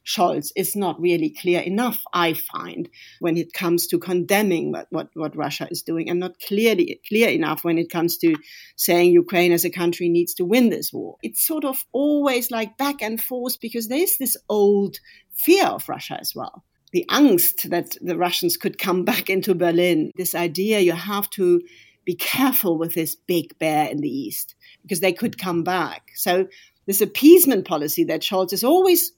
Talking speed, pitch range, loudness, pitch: 190 wpm, 170-240 Hz, -20 LUFS, 185 Hz